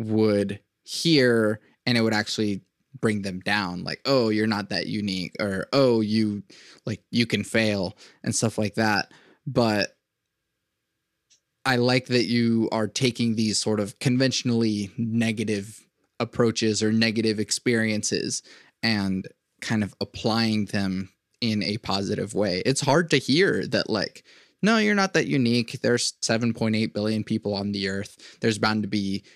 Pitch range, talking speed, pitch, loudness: 105-120 Hz, 150 wpm, 110 Hz, -24 LUFS